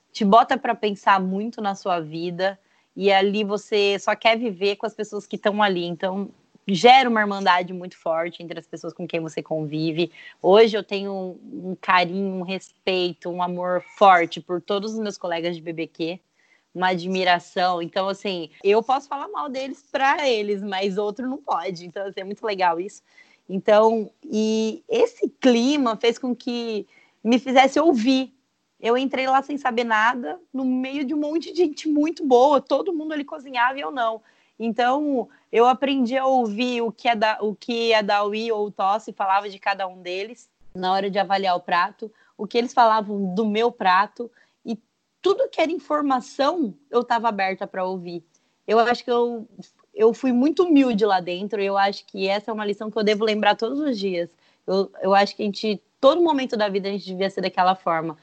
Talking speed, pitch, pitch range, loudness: 195 wpm, 210 Hz, 190-245 Hz, -22 LUFS